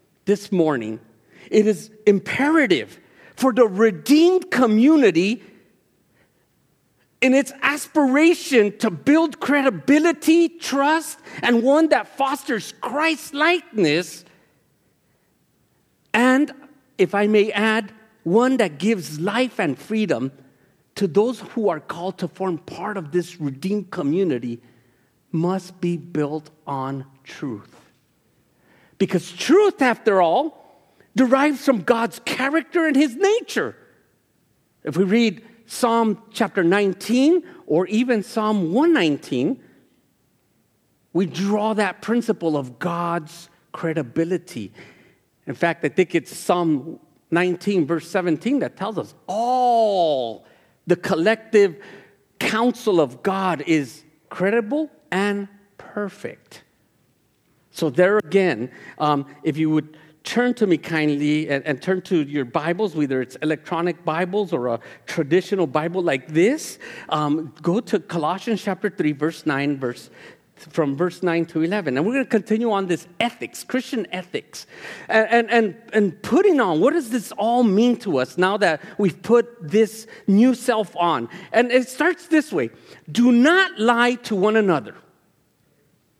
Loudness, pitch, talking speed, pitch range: -20 LUFS, 200 Hz, 125 wpm, 165-240 Hz